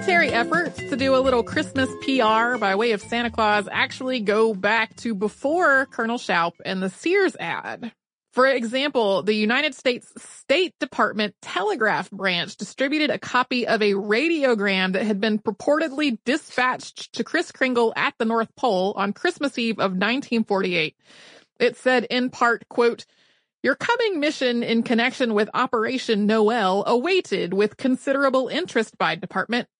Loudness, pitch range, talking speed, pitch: -22 LUFS, 215-265 Hz, 150 wpm, 235 Hz